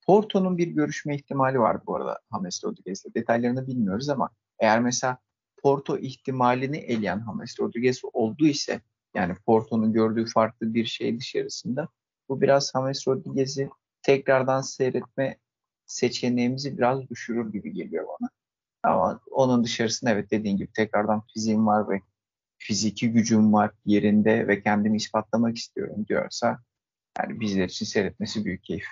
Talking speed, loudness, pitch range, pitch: 135 wpm, -25 LUFS, 110-135 Hz, 120 Hz